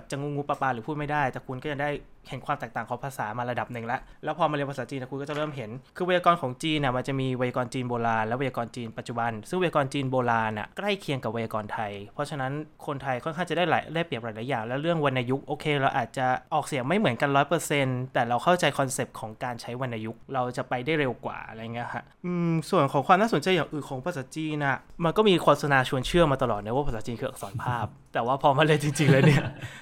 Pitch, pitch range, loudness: 135 Hz, 125-150 Hz, -27 LUFS